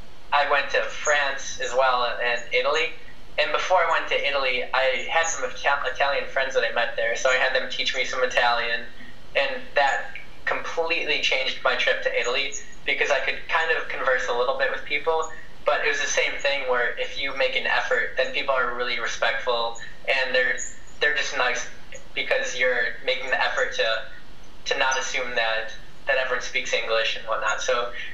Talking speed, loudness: 190 wpm, -23 LUFS